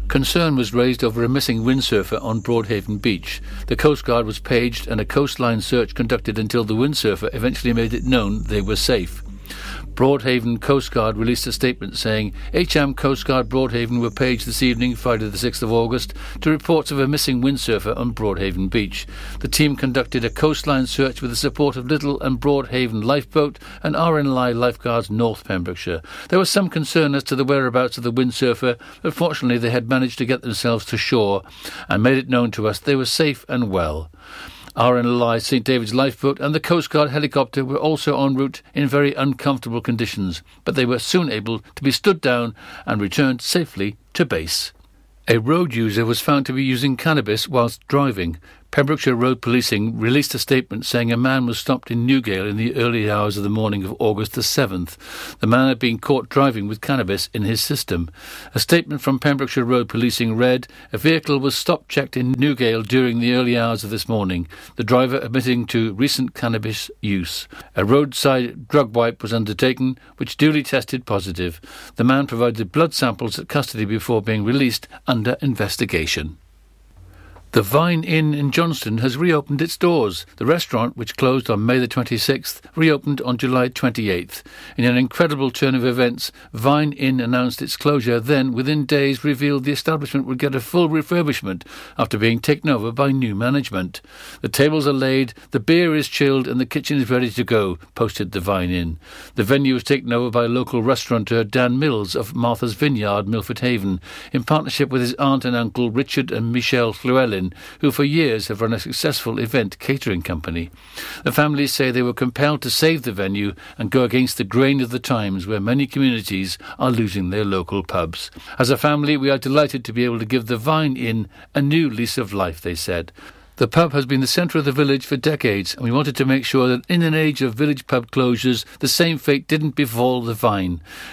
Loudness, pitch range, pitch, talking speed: -19 LUFS, 115-140 Hz, 125 Hz, 195 wpm